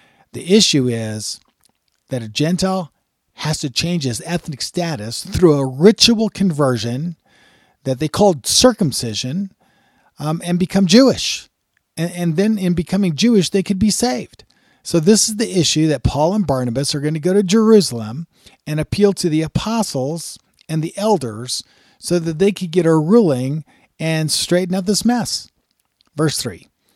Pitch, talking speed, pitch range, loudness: 170 Hz, 160 wpm, 140-200 Hz, -17 LUFS